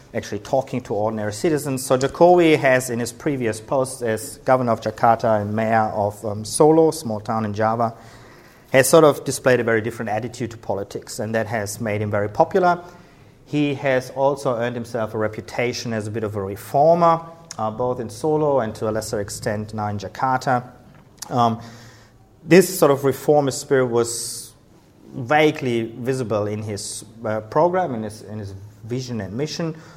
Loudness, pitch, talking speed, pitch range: -20 LUFS, 120 Hz, 175 wpm, 110-135 Hz